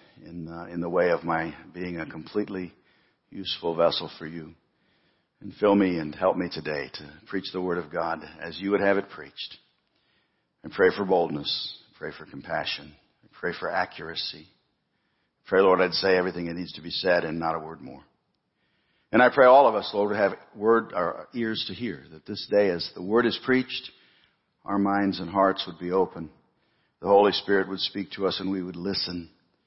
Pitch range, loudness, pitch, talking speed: 85-100 Hz, -25 LUFS, 95 Hz, 200 wpm